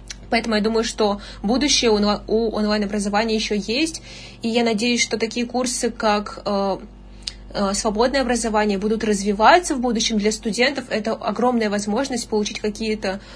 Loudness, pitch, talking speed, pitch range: -20 LUFS, 220 Hz, 130 wpm, 210-240 Hz